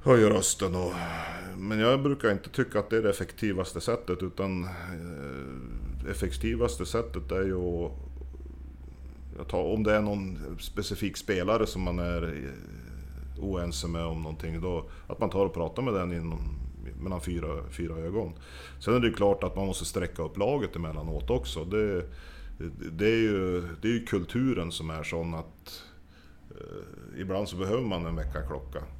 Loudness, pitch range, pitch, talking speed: -30 LUFS, 75-100 Hz, 85 Hz, 170 wpm